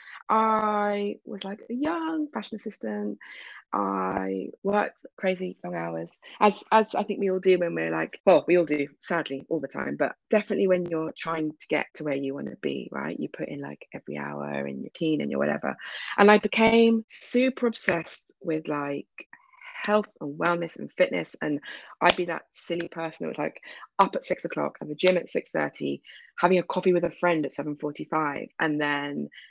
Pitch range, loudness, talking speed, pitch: 140-205 Hz, -27 LUFS, 200 wpm, 170 Hz